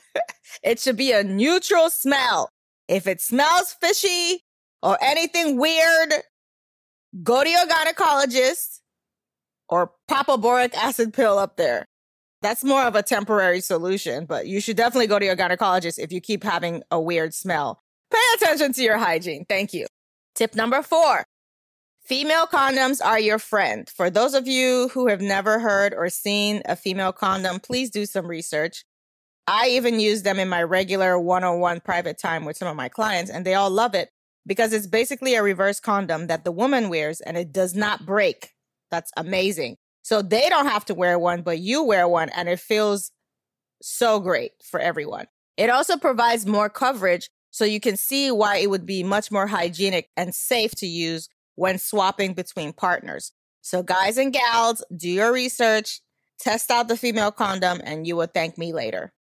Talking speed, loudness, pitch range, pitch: 180 wpm, -21 LUFS, 180-255 Hz, 210 Hz